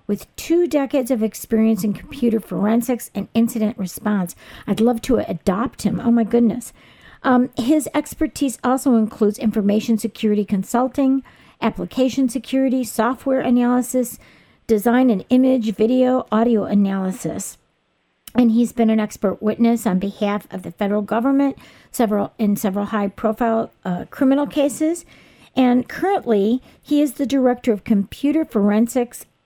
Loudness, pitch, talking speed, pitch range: -19 LUFS, 230 Hz, 130 wpm, 210-255 Hz